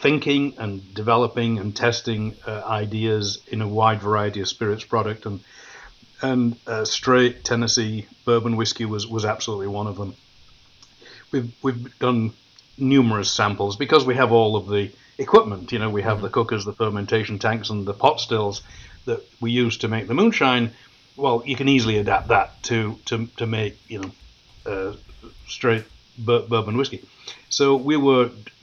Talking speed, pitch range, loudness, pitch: 165 wpm, 105-120 Hz, -22 LUFS, 110 Hz